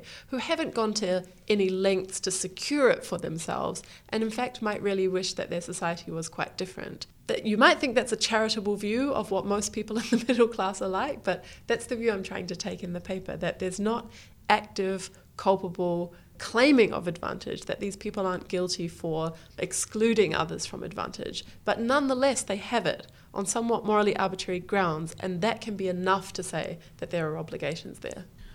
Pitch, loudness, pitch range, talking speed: 200 Hz, -28 LUFS, 185-225 Hz, 195 wpm